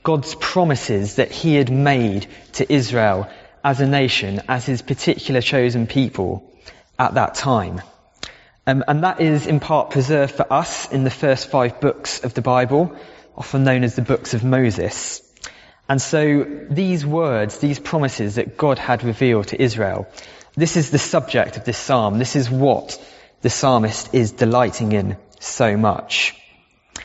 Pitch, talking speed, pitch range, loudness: 130 Hz, 160 wpm, 115-145 Hz, -19 LUFS